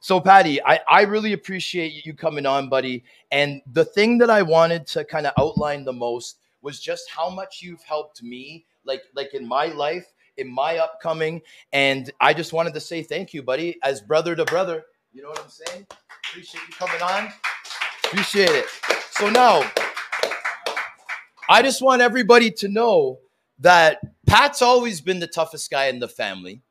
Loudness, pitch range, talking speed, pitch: -20 LUFS, 145-200 Hz, 175 wpm, 165 Hz